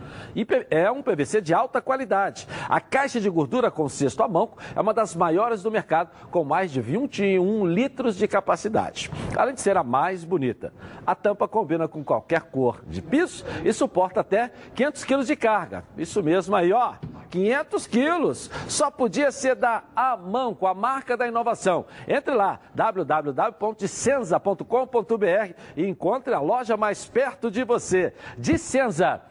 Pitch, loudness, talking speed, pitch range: 220 Hz, -24 LUFS, 155 wpm, 185-255 Hz